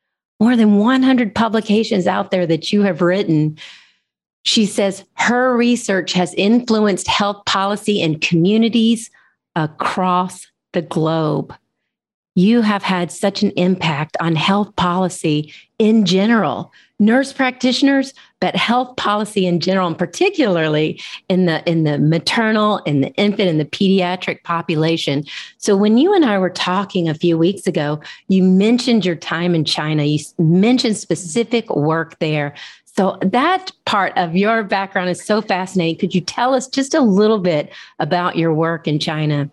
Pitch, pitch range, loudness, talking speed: 190 Hz, 170-220 Hz, -16 LUFS, 155 wpm